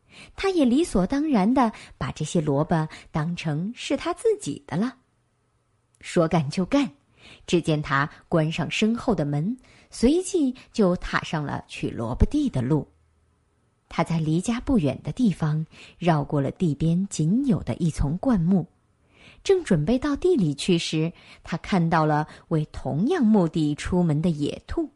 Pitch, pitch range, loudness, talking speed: 170 Hz, 150-230 Hz, -24 LUFS, 210 characters per minute